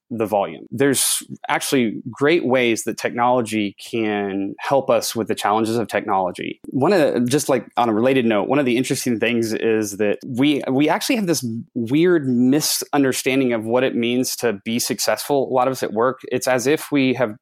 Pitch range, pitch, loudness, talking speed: 115-135 Hz, 125 Hz, -19 LUFS, 195 wpm